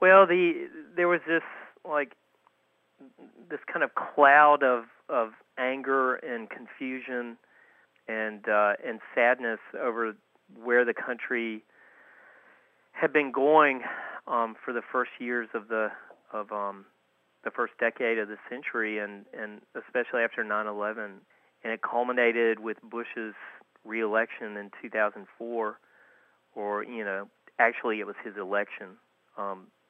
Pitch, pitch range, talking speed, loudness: 120 Hz, 110-140 Hz, 125 wpm, -28 LUFS